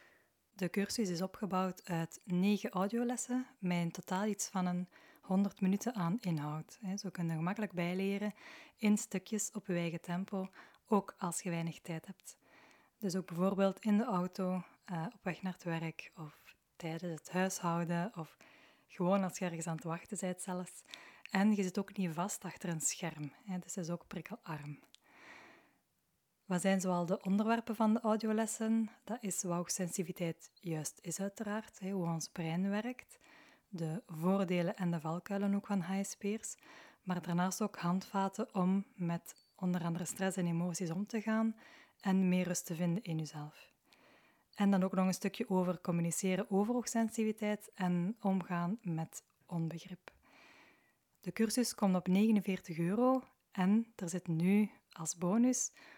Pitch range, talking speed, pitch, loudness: 175-210 Hz, 160 wpm, 190 Hz, -37 LUFS